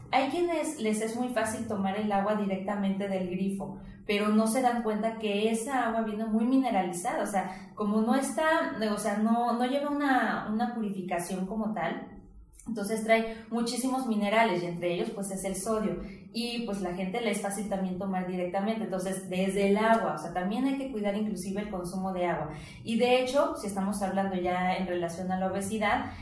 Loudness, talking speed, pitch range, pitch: -30 LUFS, 195 wpm, 190-230 Hz, 210 Hz